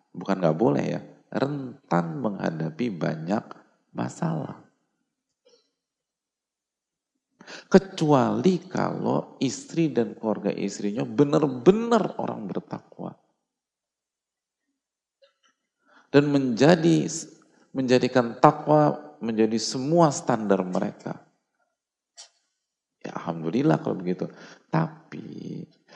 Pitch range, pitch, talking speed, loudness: 115-175 Hz, 145 Hz, 70 wpm, -24 LUFS